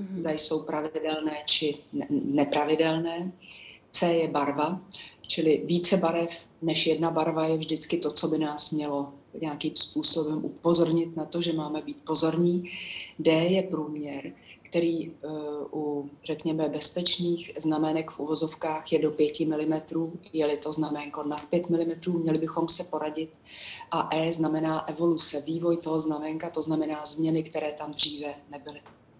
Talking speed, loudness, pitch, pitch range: 140 wpm, -27 LUFS, 155 Hz, 150-165 Hz